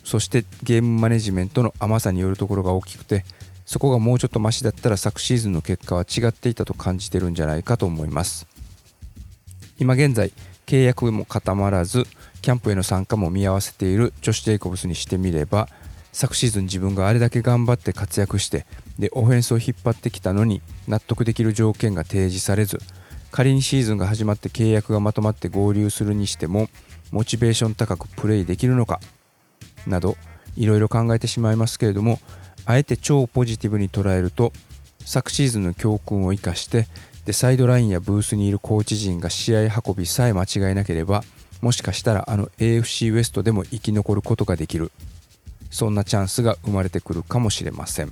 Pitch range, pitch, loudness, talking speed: 95-115 Hz, 105 Hz, -21 LUFS, 410 characters per minute